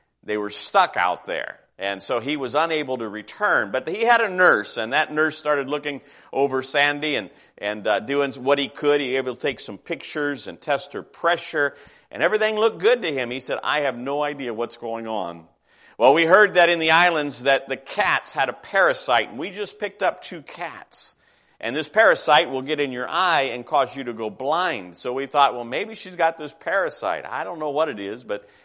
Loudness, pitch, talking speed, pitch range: -22 LUFS, 145 Hz, 225 wpm, 125-165 Hz